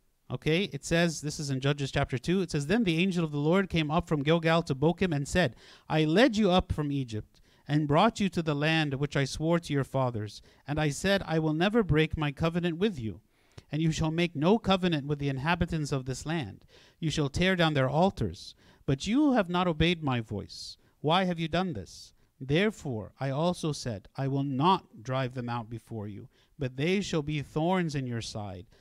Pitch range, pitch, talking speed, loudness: 130-170 Hz, 150 Hz, 215 wpm, -29 LUFS